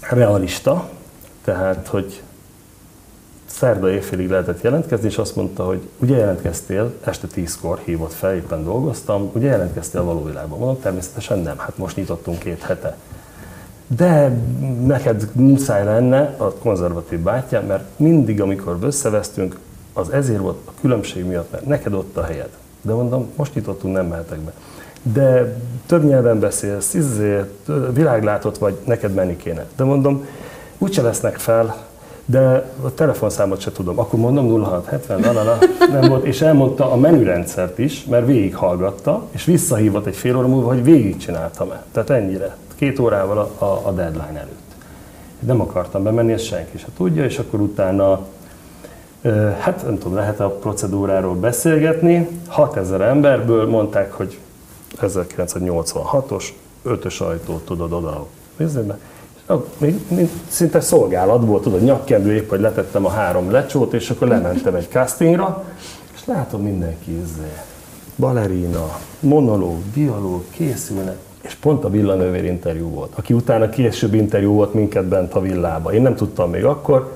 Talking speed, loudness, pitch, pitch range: 140 wpm, -18 LUFS, 110 Hz, 95-135 Hz